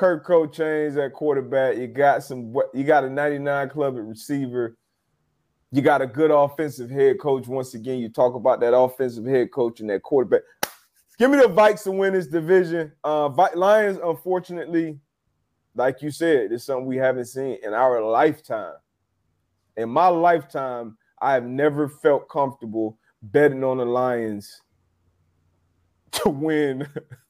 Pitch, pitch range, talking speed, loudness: 135 Hz, 120-160 Hz, 155 wpm, -22 LUFS